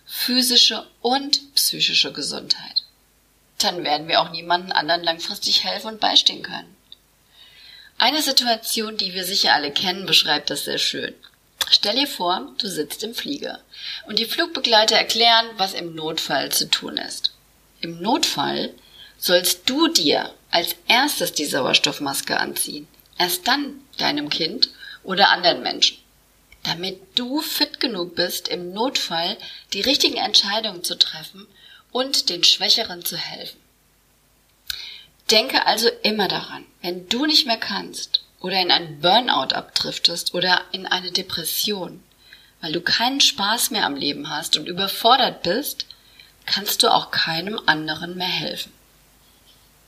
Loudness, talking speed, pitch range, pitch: -19 LUFS, 135 wpm, 175-255 Hz, 200 Hz